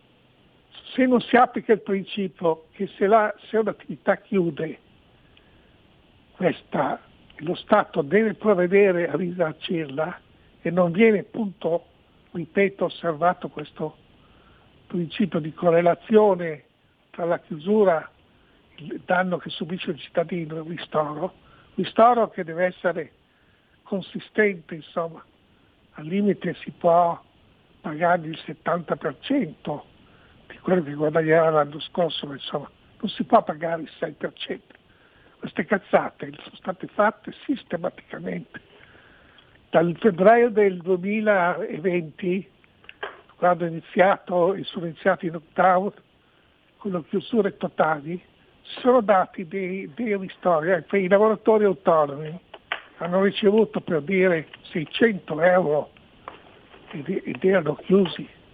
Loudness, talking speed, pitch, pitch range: -23 LUFS, 110 wpm, 180 Hz, 165-200 Hz